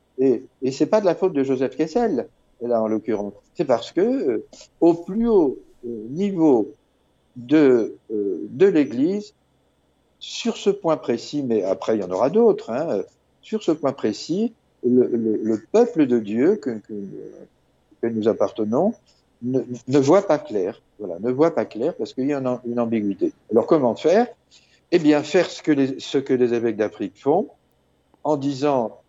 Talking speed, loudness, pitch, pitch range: 185 wpm, -21 LUFS, 135 Hz, 115-180 Hz